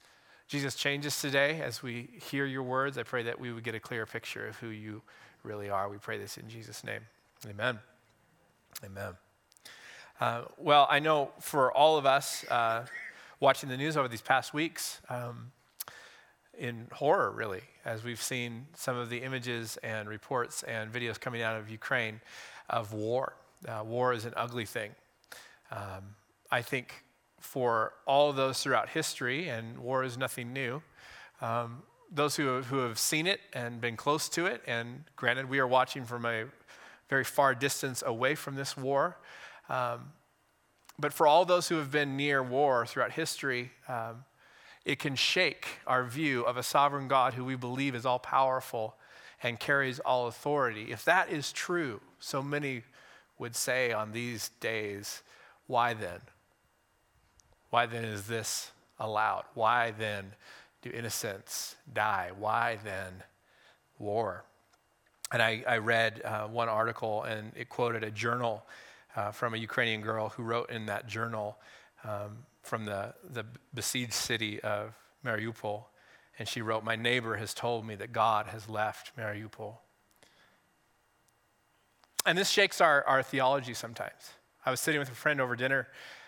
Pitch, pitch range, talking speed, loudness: 120 Hz, 110-135 Hz, 160 wpm, -32 LUFS